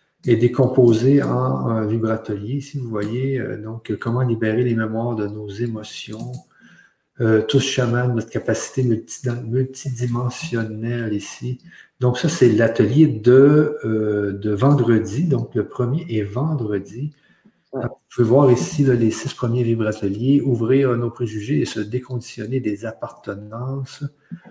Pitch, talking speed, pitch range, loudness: 120 Hz, 130 wpm, 110-135 Hz, -20 LUFS